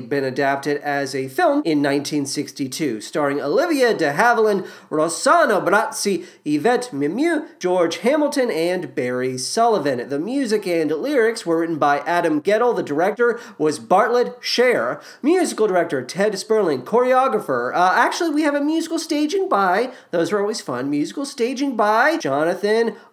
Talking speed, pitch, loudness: 145 wpm, 210 Hz, -19 LUFS